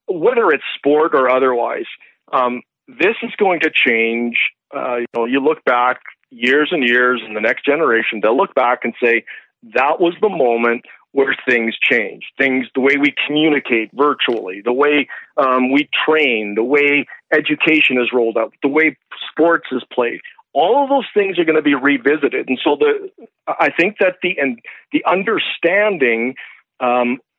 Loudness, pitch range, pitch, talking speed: -16 LUFS, 125-160 Hz, 140 Hz, 170 wpm